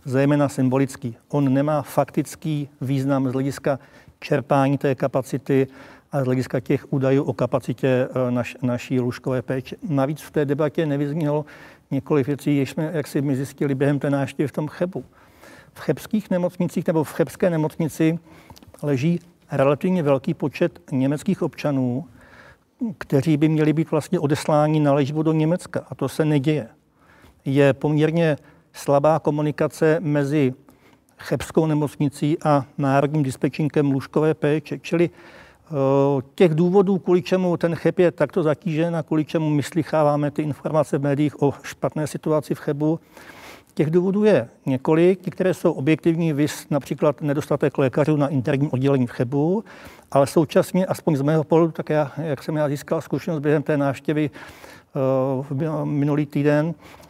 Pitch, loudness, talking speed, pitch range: 150 Hz, -22 LUFS, 145 wpm, 140-160 Hz